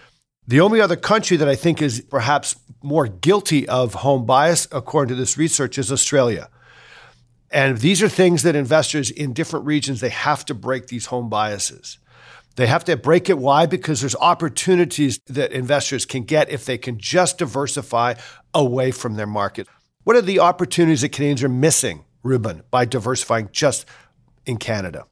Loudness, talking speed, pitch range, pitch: -19 LUFS, 170 wpm, 125-160 Hz, 140 Hz